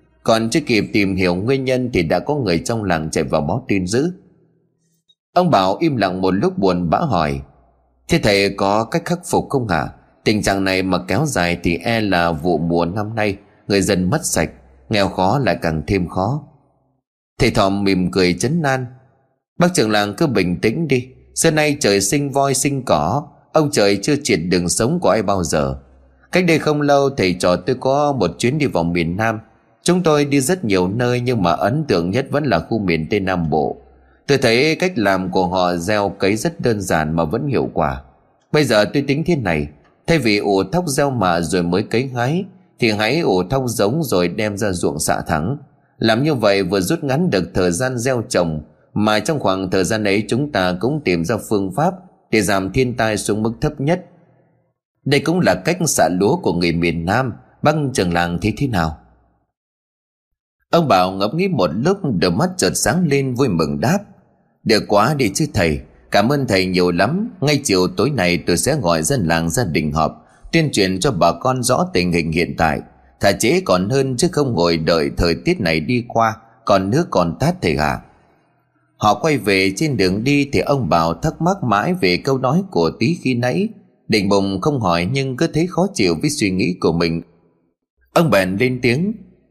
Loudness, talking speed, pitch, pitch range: -17 LUFS, 210 wpm, 110 Hz, 90-140 Hz